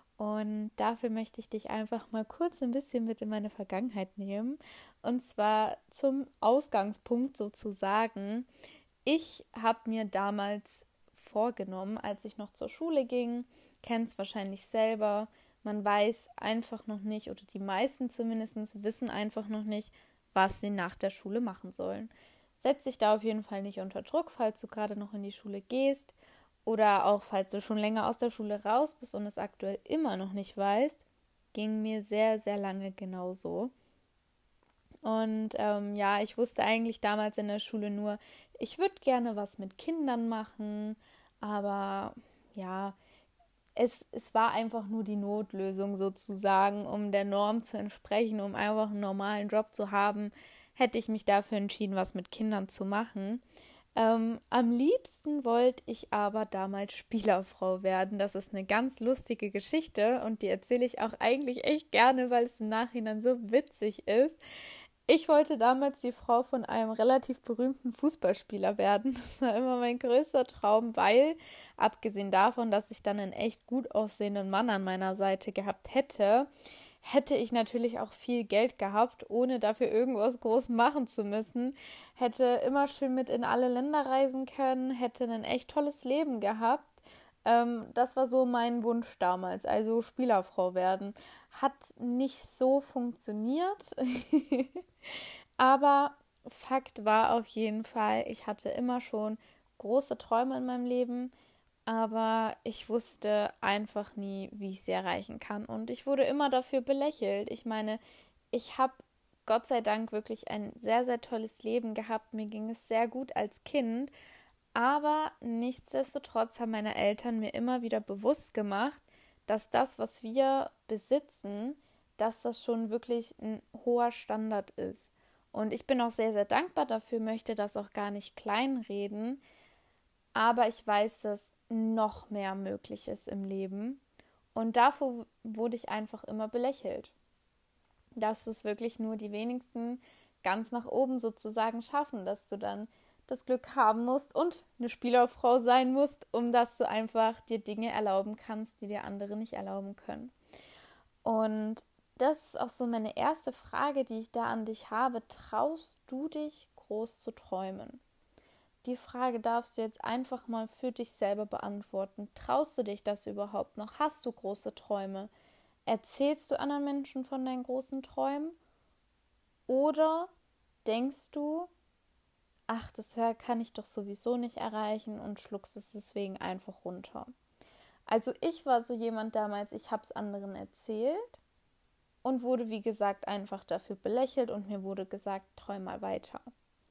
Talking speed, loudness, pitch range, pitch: 155 wpm, -33 LUFS, 210-255 Hz, 225 Hz